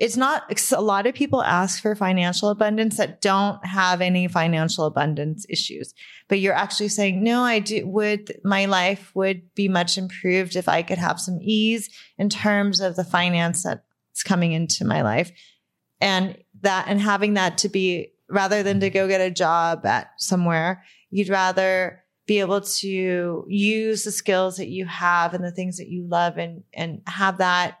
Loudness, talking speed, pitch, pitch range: -22 LUFS, 180 wpm, 190 Hz, 180-205 Hz